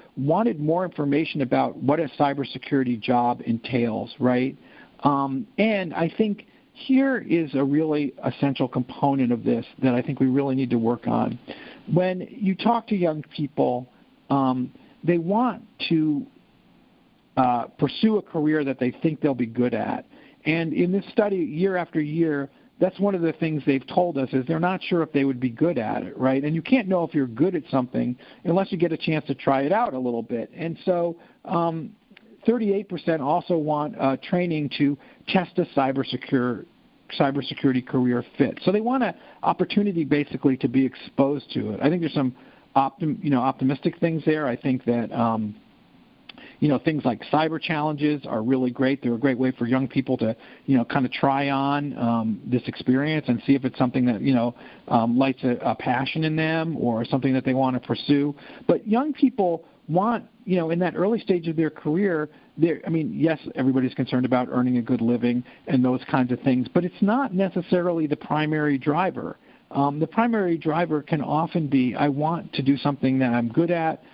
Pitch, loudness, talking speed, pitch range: 145 Hz, -24 LUFS, 195 wpm, 130-175 Hz